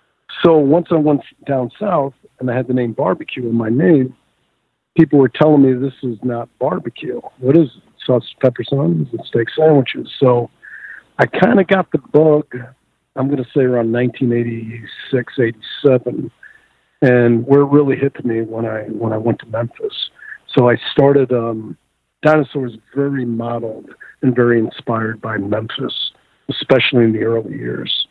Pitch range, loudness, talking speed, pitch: 115-140 Hz, -16 LUFS, 160 wpm, 130 Hz